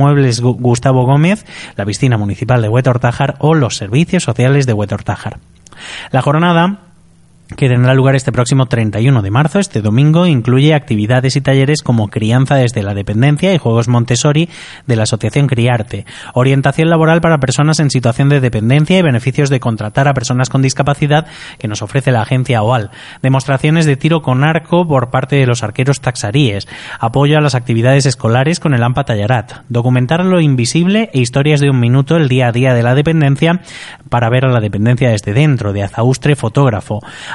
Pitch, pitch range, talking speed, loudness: 130 Hz, 120-145 Hz, 175 wpm, -12 LUFS